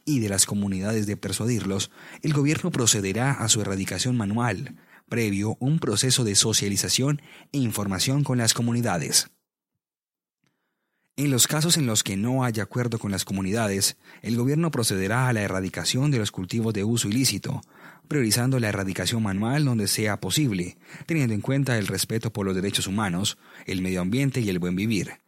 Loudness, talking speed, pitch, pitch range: -24 LUFS, 165 wpm, 110 Hz, 100-130 Hz